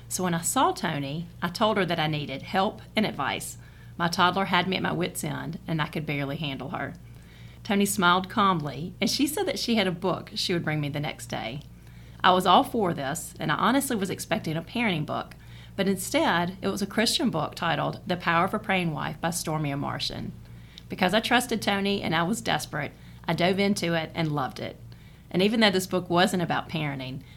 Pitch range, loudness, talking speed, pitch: 150-200 Hz, -26 LUFS, 215 wpm, 175 Hz